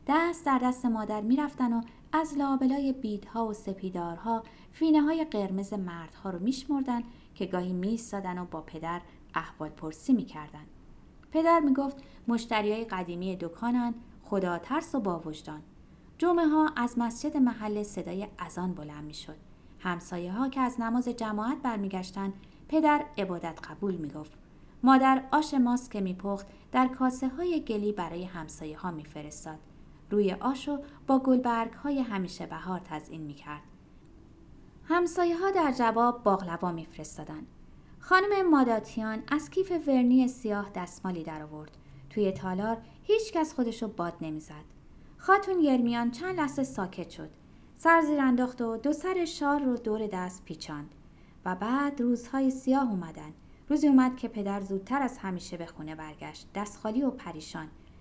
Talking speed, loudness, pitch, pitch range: 140 wpm, -30 LUFS, 220 Hz, 175-265 Hz